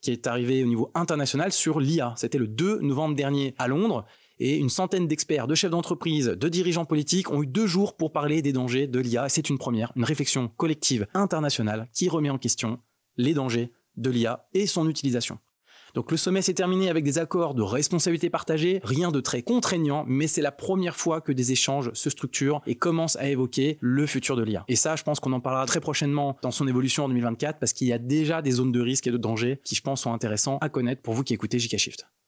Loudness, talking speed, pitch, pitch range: -25 LUFS, 230 wpm, 140 Hz, 125-160 Hz